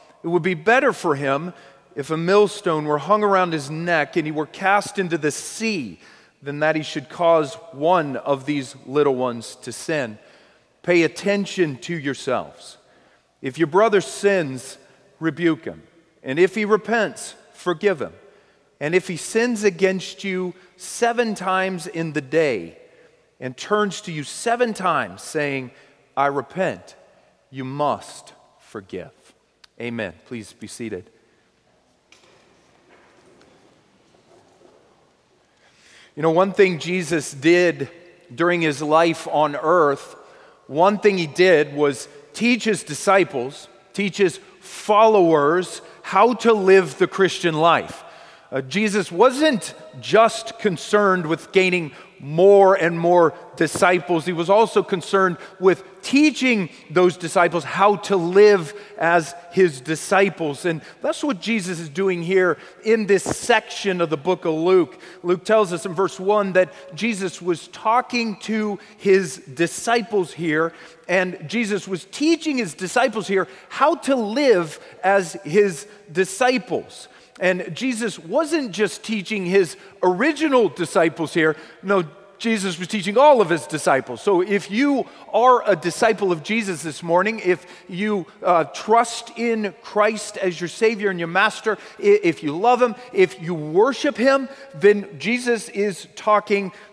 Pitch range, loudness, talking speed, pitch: 165-210 Hz, -20 LUFS, 135 wpm, 185 Hz